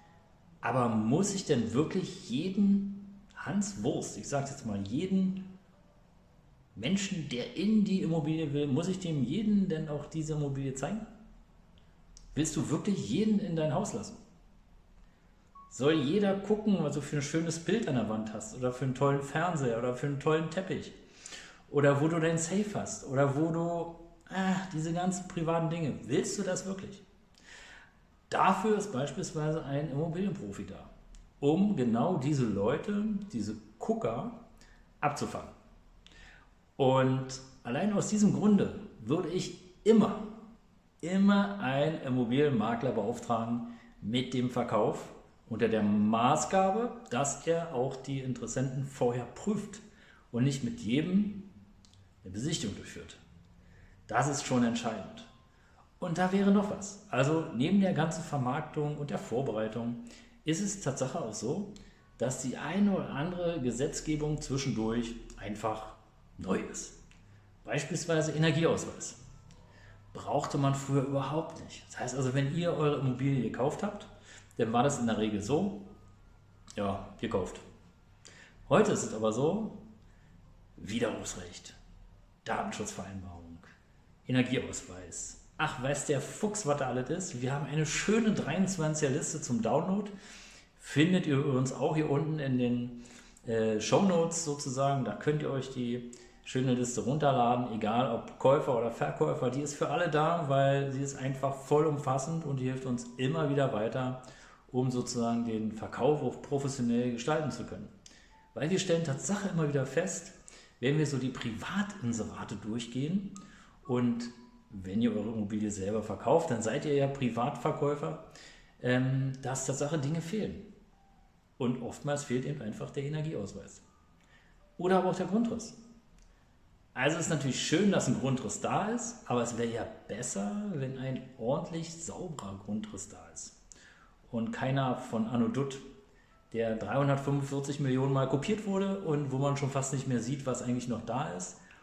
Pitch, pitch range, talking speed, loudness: 140 Hz, 120-170 Hz, 145 wpm, -32 LUFS